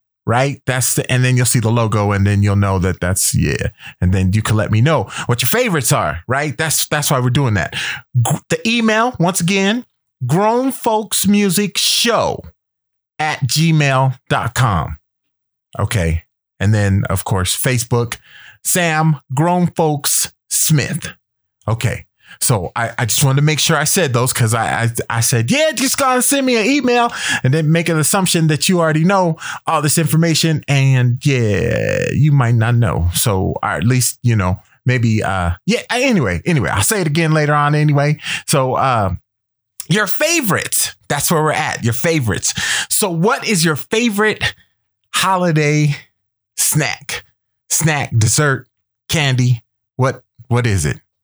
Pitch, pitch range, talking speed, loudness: 135 Hz, 115-165 Hz, 165 wpm, -15 LUFS